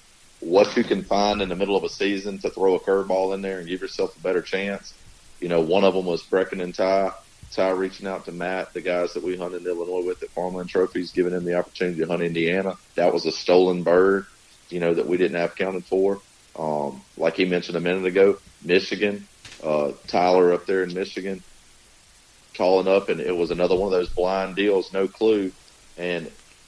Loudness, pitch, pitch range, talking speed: -23 LUFS, 95 Hz, 90-95 Hz, 215 wpm